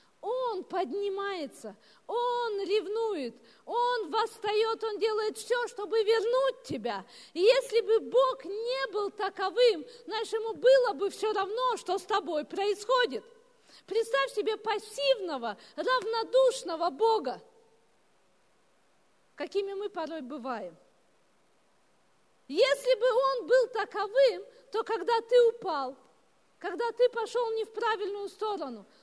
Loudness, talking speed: -29 LUFS, 110 wpm